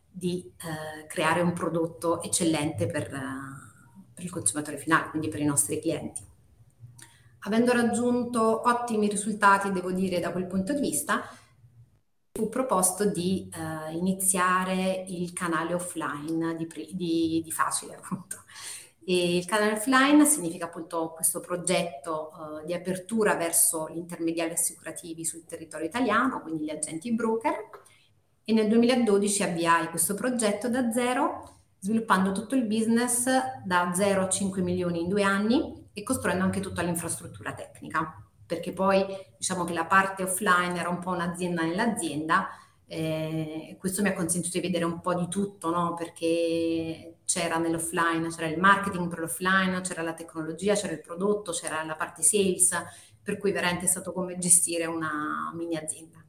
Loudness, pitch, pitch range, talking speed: -27 LUFS, 175 Hz, 160-195 Hz, 150 wpm